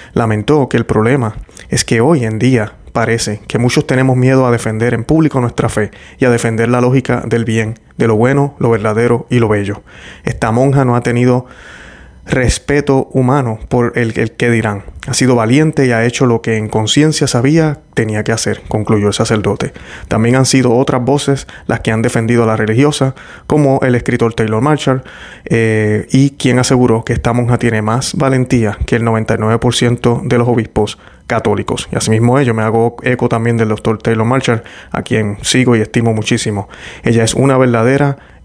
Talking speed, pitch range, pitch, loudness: 185 wpm, 110-130 Hz, 120 Hz, -13 LUFS